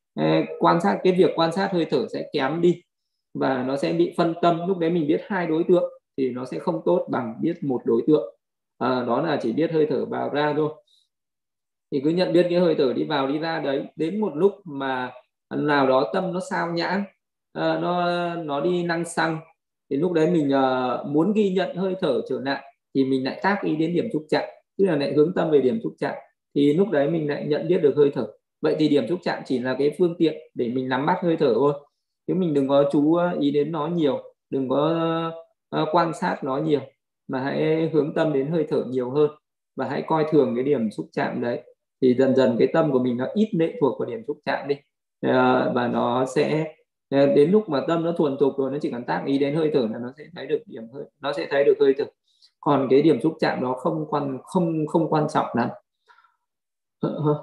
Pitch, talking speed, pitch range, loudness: 155 Hz, 230 wpm, 140-175 Hz, -23 LUFS